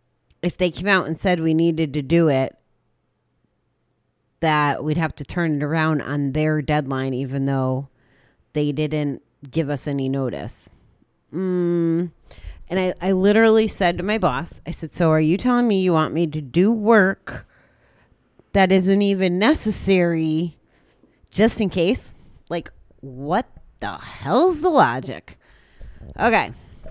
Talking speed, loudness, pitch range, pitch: 145 wpm, -20 LUFS, 150-190 Hz, 165 Hz